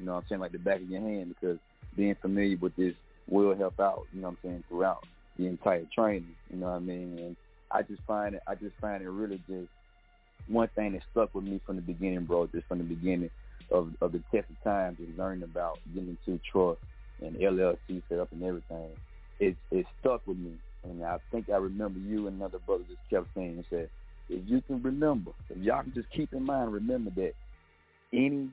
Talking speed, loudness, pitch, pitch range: 235 wpm, -33 LUFS, 95 Hz, 85-105 Hz